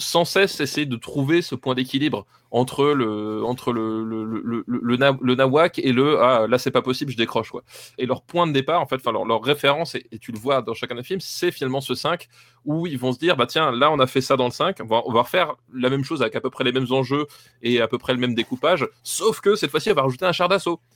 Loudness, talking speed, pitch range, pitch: -21 LUFS, 280 wpm, 120-150 Hz, 135 Hz